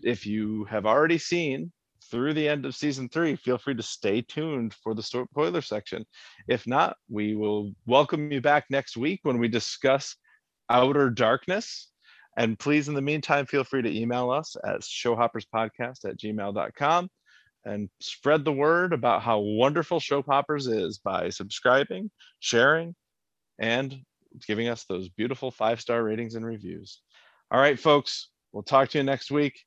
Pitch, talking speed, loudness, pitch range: 125 Hz, 160 wpm, -26 LUFS, 110-145 Hz